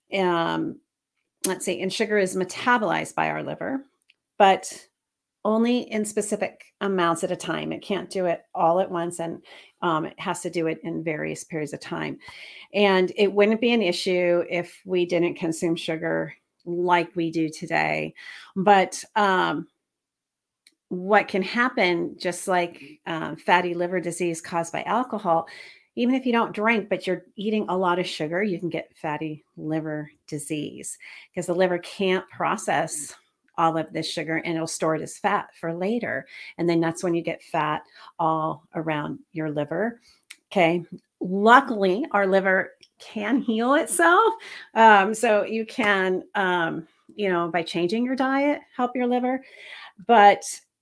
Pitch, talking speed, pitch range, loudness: 180 Hz, 160 wpm, 165-210 Hz, -24 LUFS